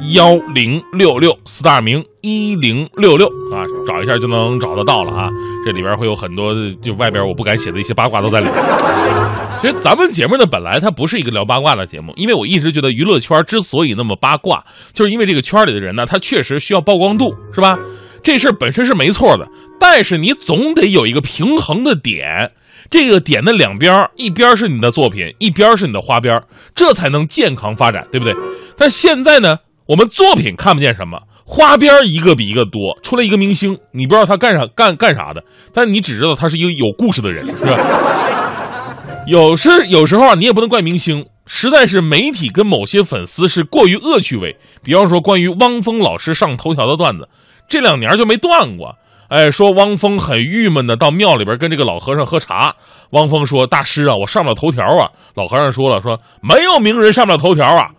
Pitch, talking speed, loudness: 160 Hz, 320 characters per minute, -12 LUFS